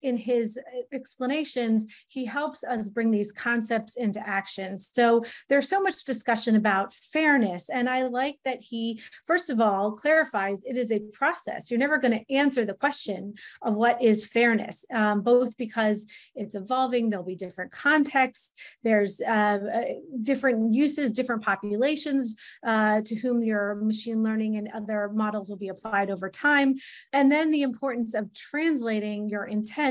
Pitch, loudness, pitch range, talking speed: 230 Hz, -26 LUFS, 210-265 Hz, 160 wpm